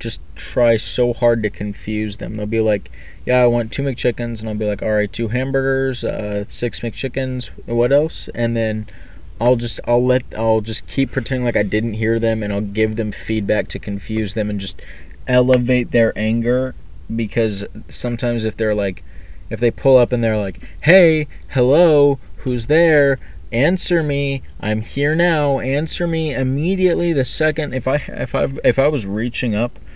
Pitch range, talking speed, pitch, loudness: 105-130 Hz, 180 wpm, 120 Hz, -18 LUFS